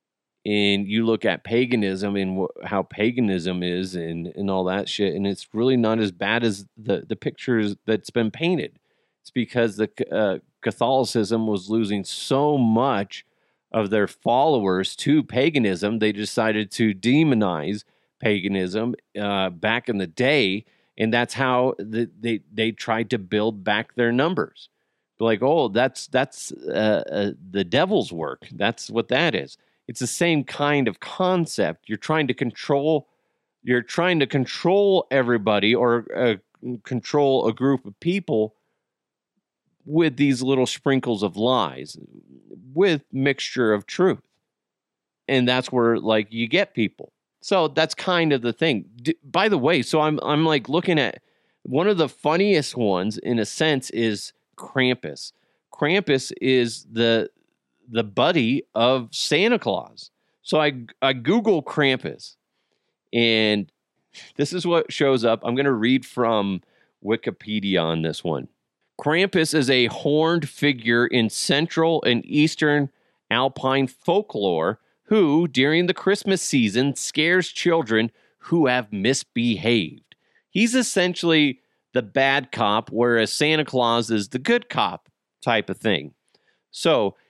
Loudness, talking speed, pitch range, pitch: -22 LUFS, 140 wpm, 110-150 Hz, 125 Hz